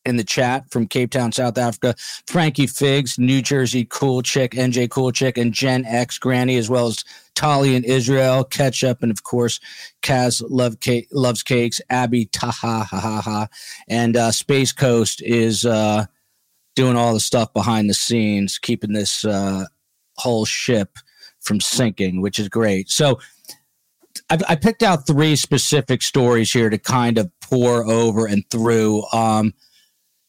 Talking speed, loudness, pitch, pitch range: 160 wpm, -18 LUFS, 120 Hz, 110-130 Hz